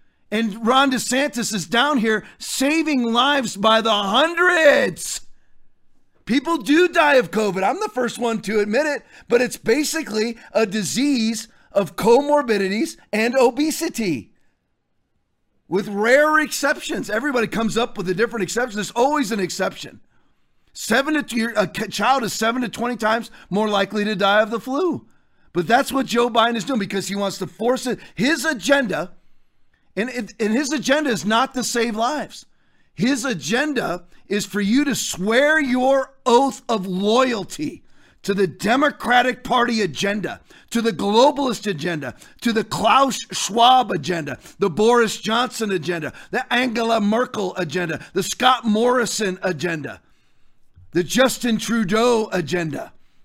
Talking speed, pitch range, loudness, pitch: 145 wpm, 205-260 Hz, -20 LUFS, 230 Hz